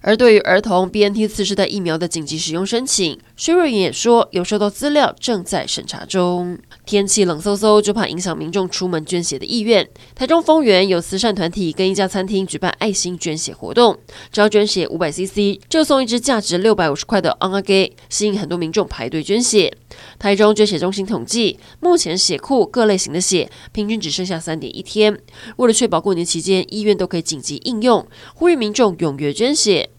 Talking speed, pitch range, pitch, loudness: 320 characters per minute, 180-215 Hz, 200 Hz, -17 LUFS